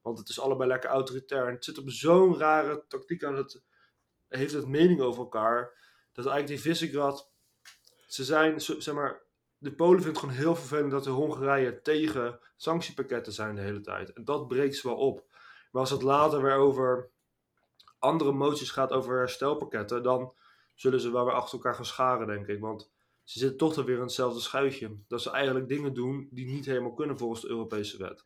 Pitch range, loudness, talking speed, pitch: 125-145 Hz, -29 LUFS, 200 wpm, 135 Hz